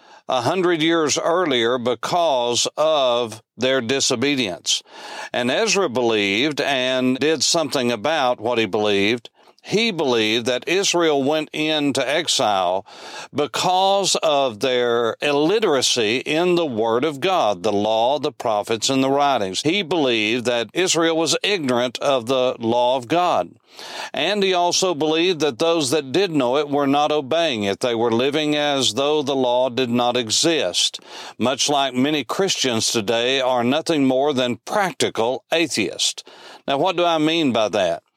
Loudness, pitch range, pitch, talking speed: -19 LUFS, 120-160 Hz, 140 Hz, 150 wpm